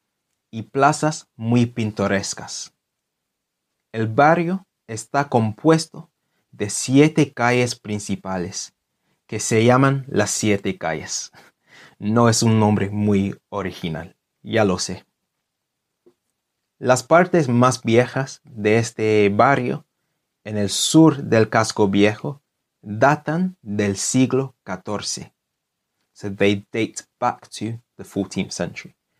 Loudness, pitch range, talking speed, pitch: -20 LUFS, 105-135 Hz, 105 wpm, 115 Hz